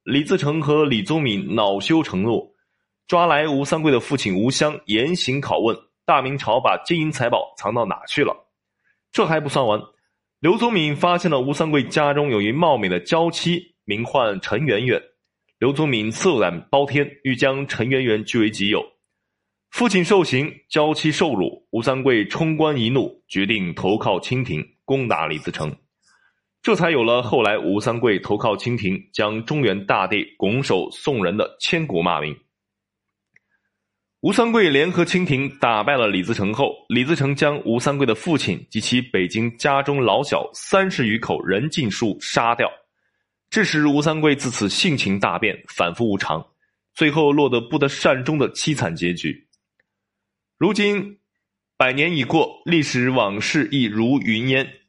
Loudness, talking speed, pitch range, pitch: -20 LUFS, 240 characters per minute, 115-160 Hz, 140 Hz